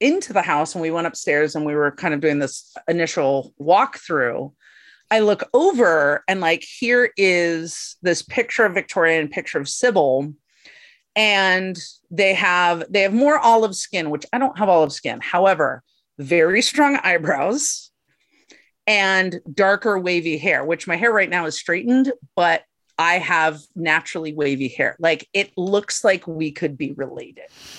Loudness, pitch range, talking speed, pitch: -19 LUFS, 155-205 Hz, 160 wpm, 175 Hz